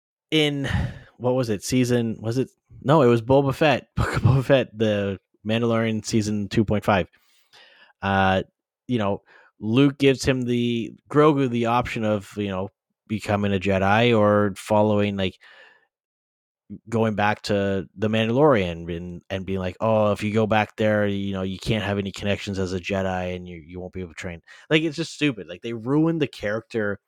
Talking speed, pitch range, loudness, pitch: 175 wpm, 95-120 Hz, -23 LUFS, 105 Hz